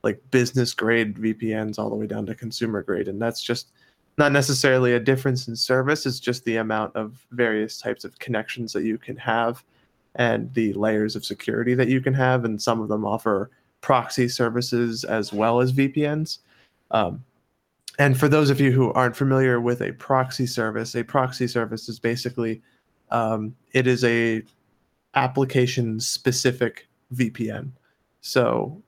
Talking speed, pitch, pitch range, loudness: 165 wpm, 120 Hz, 110-130 Hz, -23 LUFS